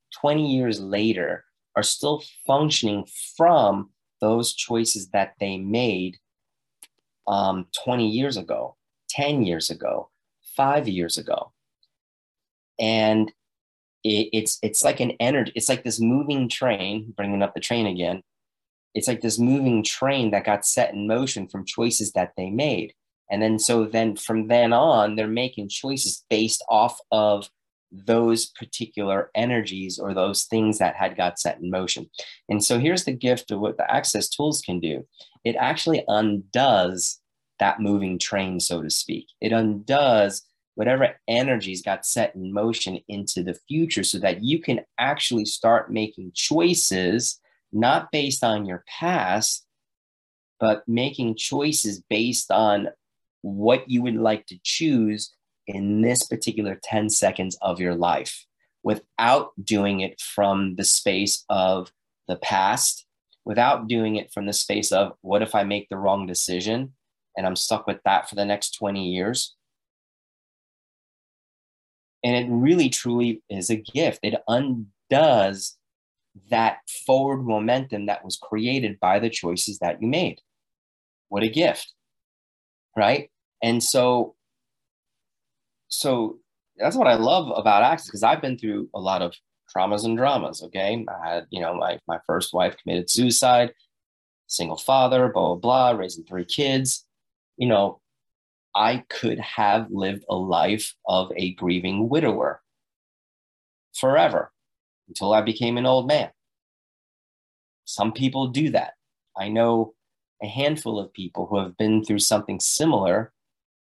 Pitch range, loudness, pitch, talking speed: 95-120 Hz, -23 LUFS, 110 Hz, 145 wpm